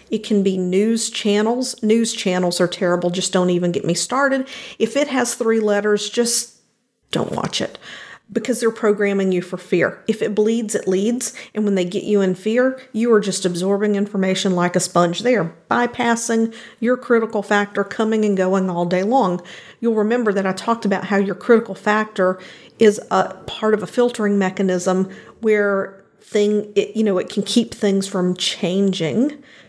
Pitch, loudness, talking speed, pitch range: 210 Hz, -19 LUFS, 180 wpm, 190-230 Hz